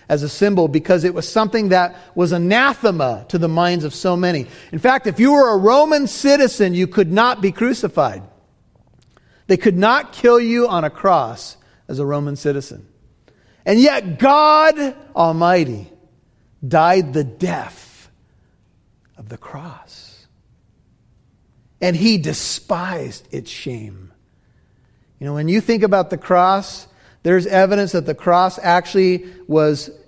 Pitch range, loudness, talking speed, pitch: 150-215 Hz, -16 LUFS, 140 wpm, 180 Hz